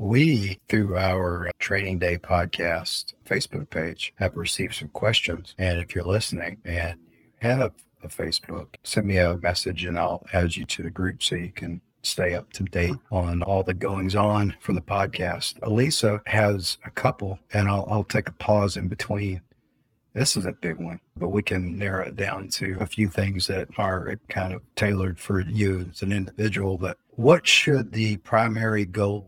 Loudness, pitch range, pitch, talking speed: -25 LUFS, 90-105 Hz, 95 Hz, 185 wpm